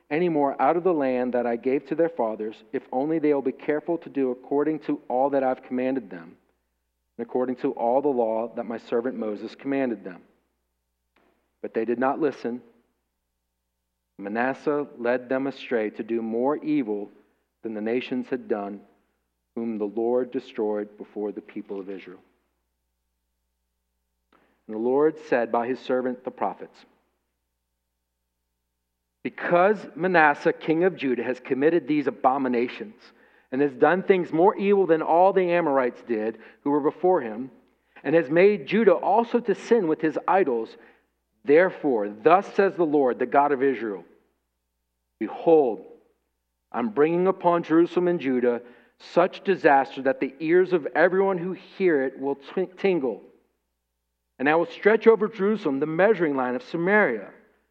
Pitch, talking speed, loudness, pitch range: 130 Hz, 155 wpm, -24 LUFS, 105-165 Hz